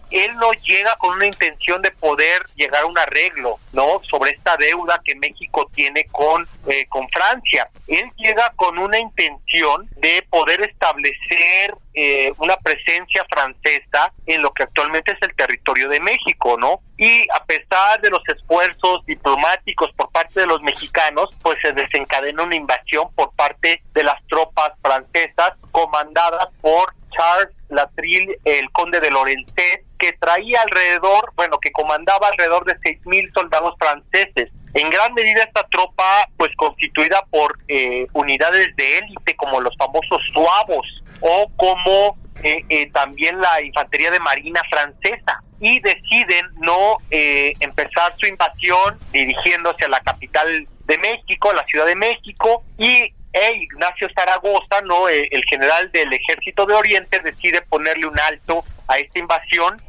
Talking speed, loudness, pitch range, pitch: 150 wpm, -16 LUFS, 155-200 Hz, 175 Hz